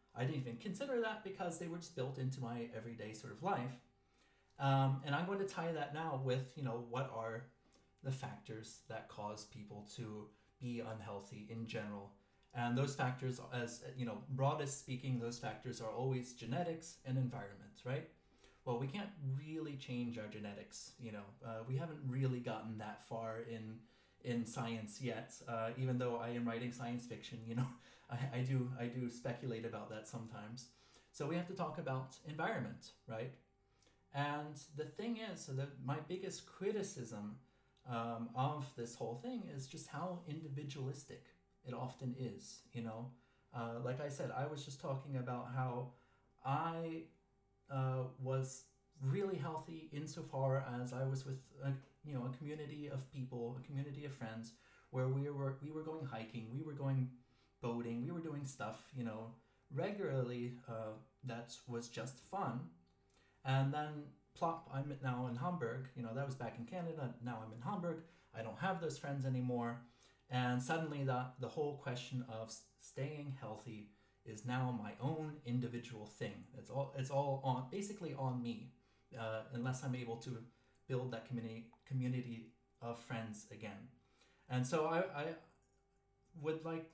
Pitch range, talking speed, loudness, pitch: 115-140 Hz, 170 wpm, -44 LUFS, 130 Hz